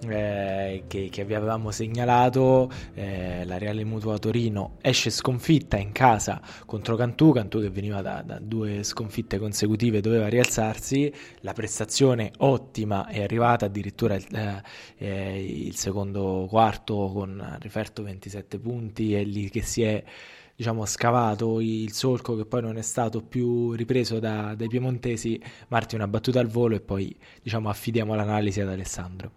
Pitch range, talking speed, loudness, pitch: 100-120 Hz, 150 wpm, -26 LUFS, 110 Hz